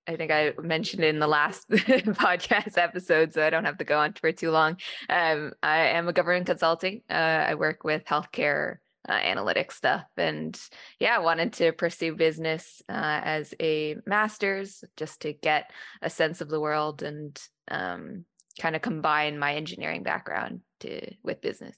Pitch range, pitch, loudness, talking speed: 155-180 Hz, 160 Hz, -26 LUFS, 175 wpm